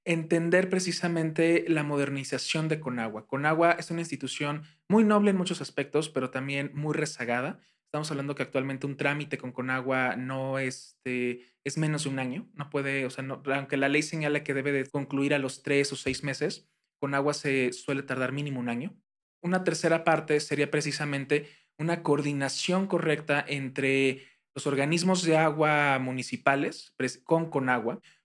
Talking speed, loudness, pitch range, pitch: 165 wpm, -28 LUFS, 135-155 Hz, 145 Hz